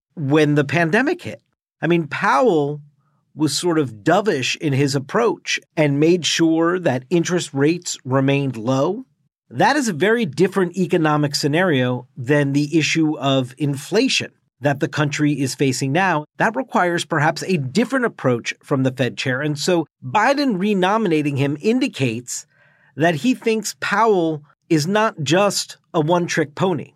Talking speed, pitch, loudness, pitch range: 150 wpm, 155 Hz, -19 LUFS, 145-185 Hz